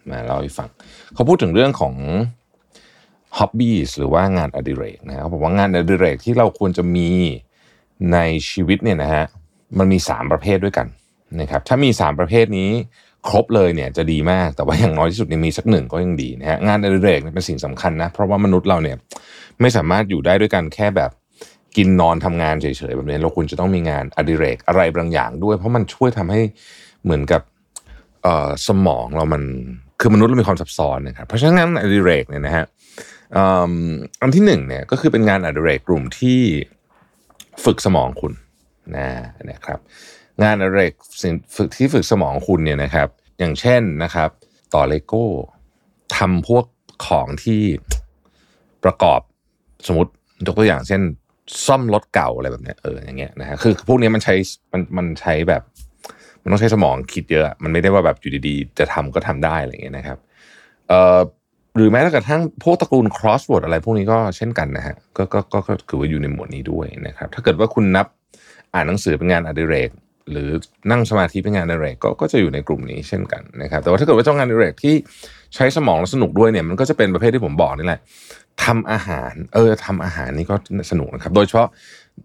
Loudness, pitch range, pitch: -17 LUFS, 80-110 Hz, 95 Hz